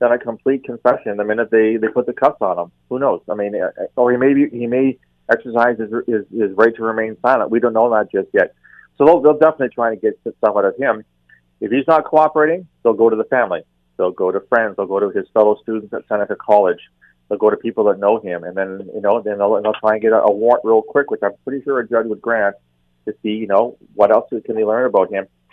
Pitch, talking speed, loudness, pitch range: 115 Hz, 265 wpm, -17 LUFS, 105-125 Hz